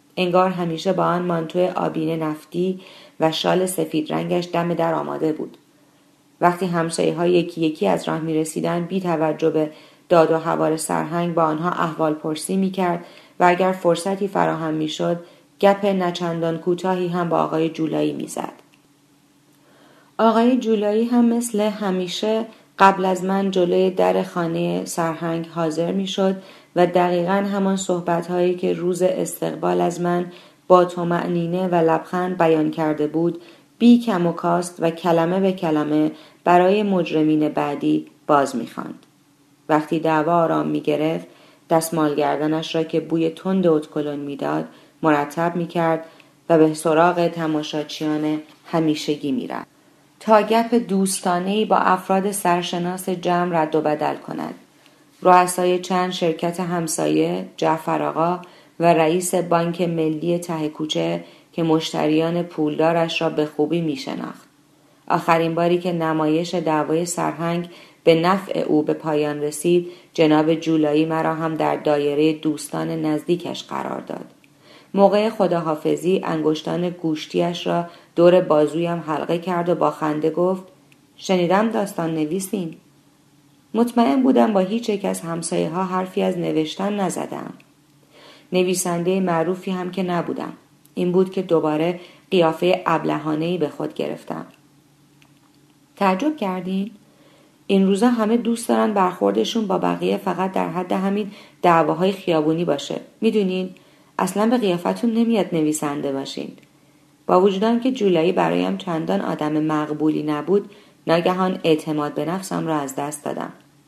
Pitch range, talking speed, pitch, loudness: 155-185 Hz, 135 wpm, 170 Hz, -20 LUFS